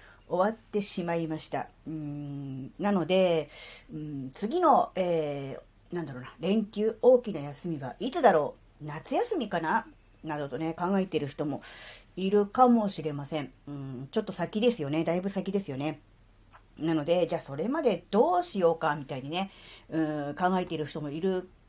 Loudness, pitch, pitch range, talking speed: -29 LUFS, 160 Hz, 145-190 Hz, 320 characters per minute